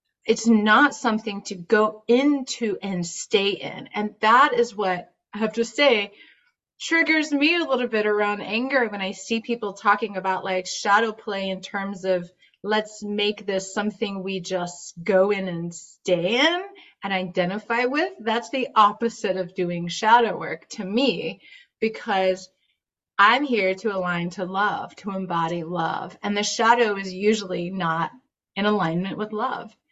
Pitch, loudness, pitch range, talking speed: 210 Hz, -23 LUFS, 190-230 Hz, 160 wpm